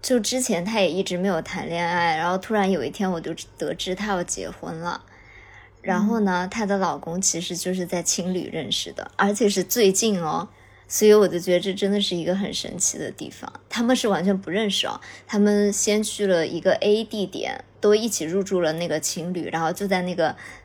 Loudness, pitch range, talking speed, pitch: -23 LUFS, 170-205 Hz, 300 characters per minute, 185 Hz